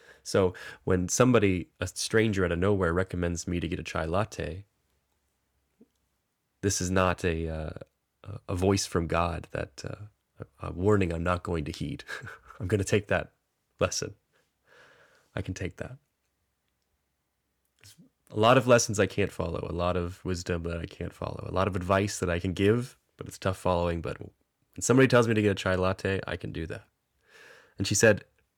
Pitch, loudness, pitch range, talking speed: 95 Hz, -28 LUFS, 85-100 Hz, 185 wpm